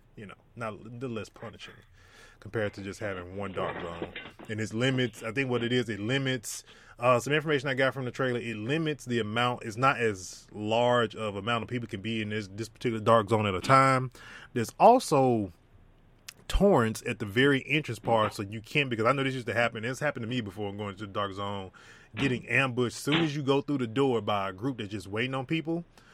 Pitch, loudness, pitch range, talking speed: 120 Hz, -28 LUFS, 110-135 Hz, 230 wpm